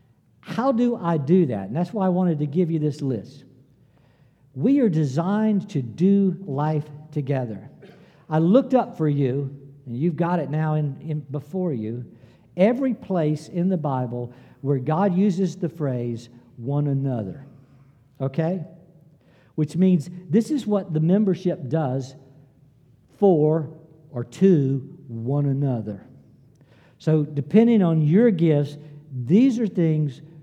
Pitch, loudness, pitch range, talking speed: 155 Hz, -22 LUFS, 135-180 Hz, 140 wpm